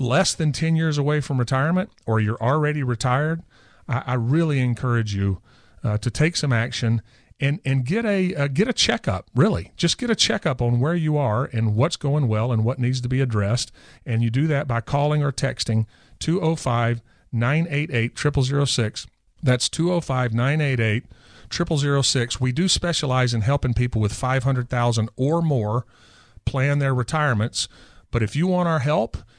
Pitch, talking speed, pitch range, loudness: 130 Hz, 165 wpm, 115-150 Hz, -22 LUFS